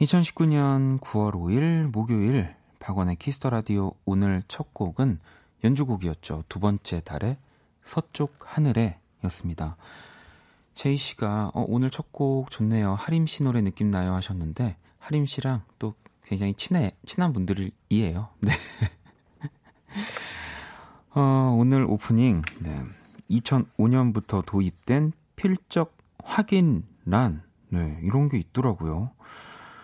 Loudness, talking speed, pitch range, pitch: -26 LUFS, 220 characters per minute, 95-140 Hz, 115 Hz